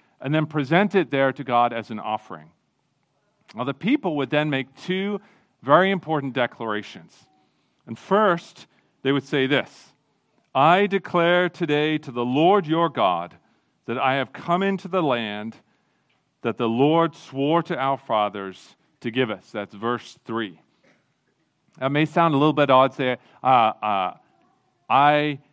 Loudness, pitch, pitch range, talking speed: -22 LUFS, 140 Hz, 120-170 Hz, 155 wpm